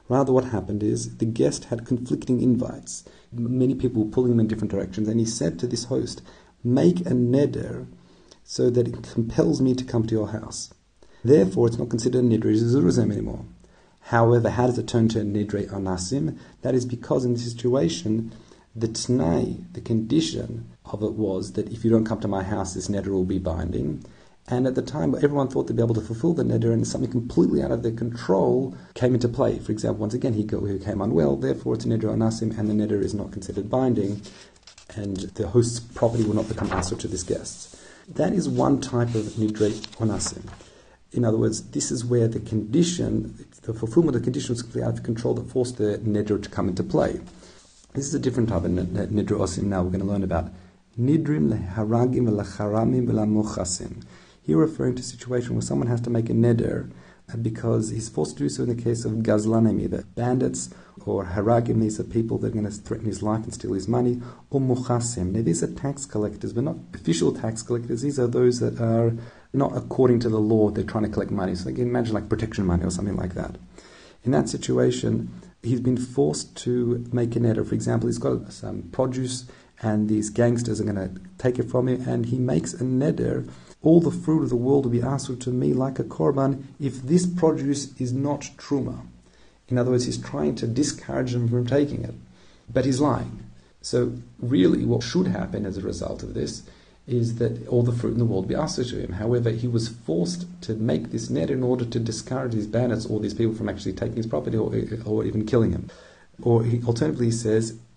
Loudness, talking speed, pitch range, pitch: -24 LUFS, 210 wpm, 105-125 Hz, 115 Hz